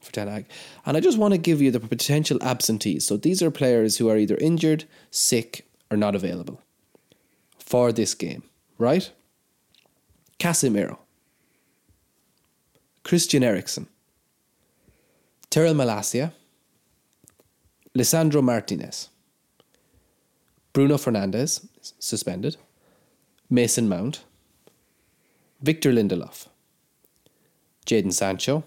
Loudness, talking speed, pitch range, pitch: -23 LUFS, 90 wpm, 110-155 Hz, 130 Hz